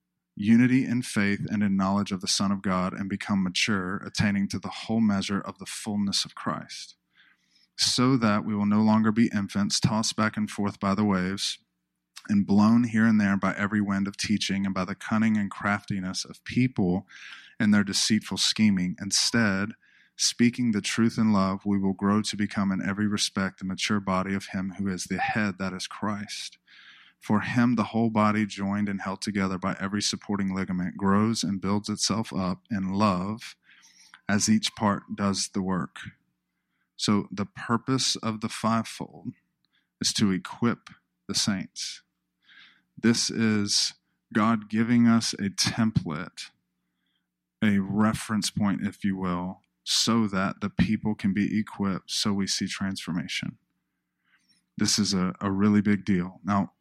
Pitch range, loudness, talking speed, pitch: 95-110 Hz, -26 LUFS, 165 wpm, 100 Hz